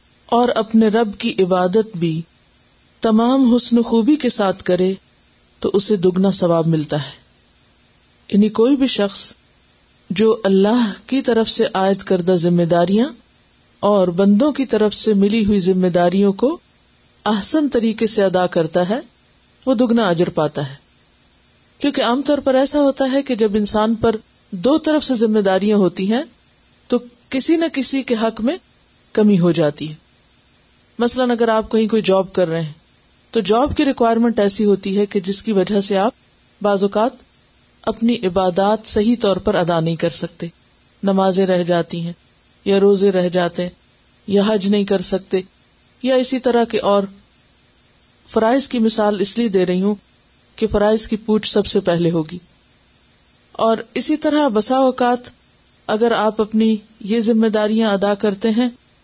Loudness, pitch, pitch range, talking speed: -17 LUFS, 215 Hz, 190-235 Hz, 170 wpm